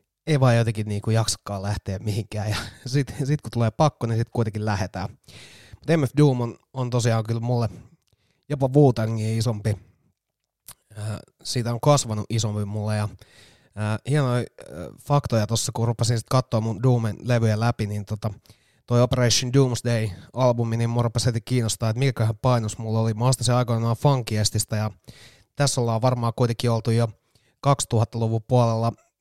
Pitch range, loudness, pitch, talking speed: 110-125 Hz, -23 LUFS, 115 Hz, 160 wpm